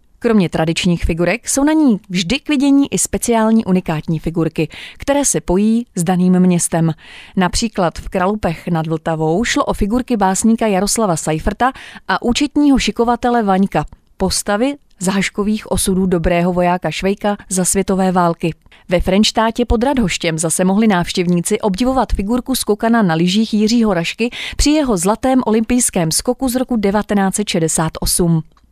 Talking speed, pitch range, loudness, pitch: 140 wpm, 180-235 Hz, -15 LUFS, 200 Hz